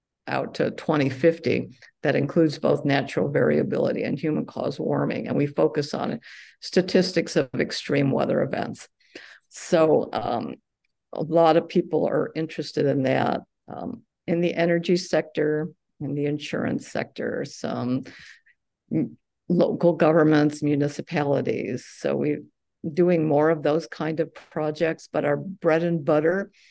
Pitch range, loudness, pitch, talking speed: 150-170 Hz, -24 LUFS, 160 Hz, 130 wpm